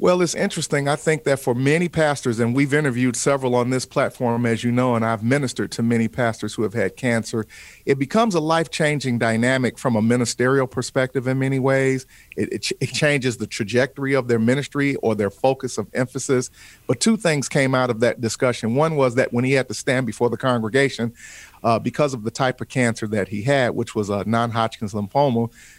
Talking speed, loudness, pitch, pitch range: 215 wpm, -21 LUFS, 125 Hz, 115-140 Hz